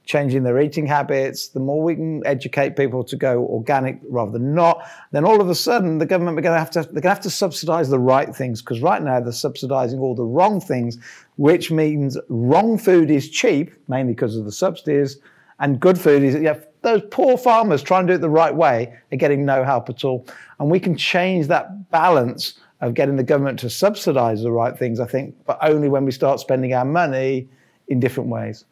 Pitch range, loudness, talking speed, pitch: 130-170 Hz, -19 LUFS, 220 wpm, 145 Hz